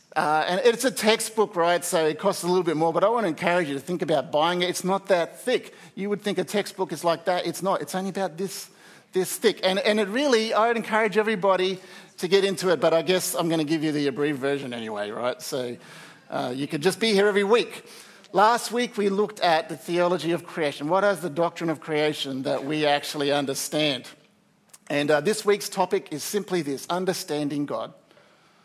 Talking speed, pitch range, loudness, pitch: 225 wpm, 155-200 Hz, -24 LUFS, 180 Hz